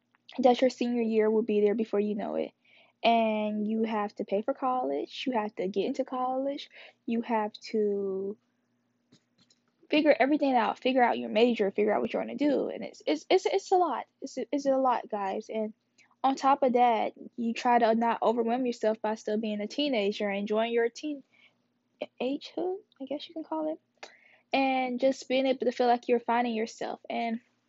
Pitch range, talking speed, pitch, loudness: 215-265 Hz, 195 wpm, 240 Hz, -29 LUFS